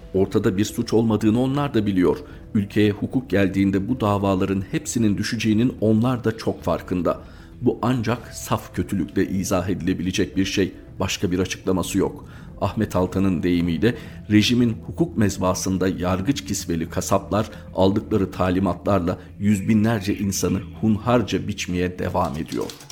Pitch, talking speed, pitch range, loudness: 100 Hz, 125 wpm, 95-110 Hz, -22 LUFS